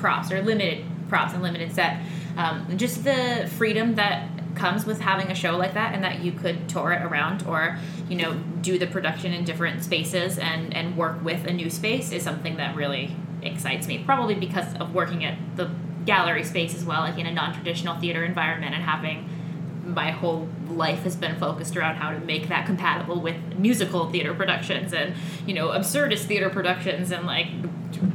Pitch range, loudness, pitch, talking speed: 165-180 Hz, -25 LUFS, 170 Hz, 190 wpm